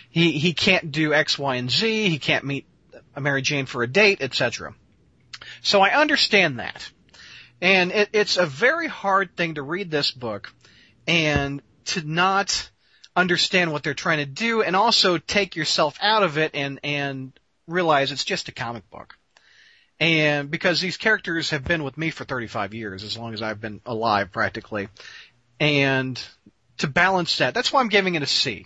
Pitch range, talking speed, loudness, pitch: 130-185 Hz, 180 wpm, -21 LUFS, 155 Hz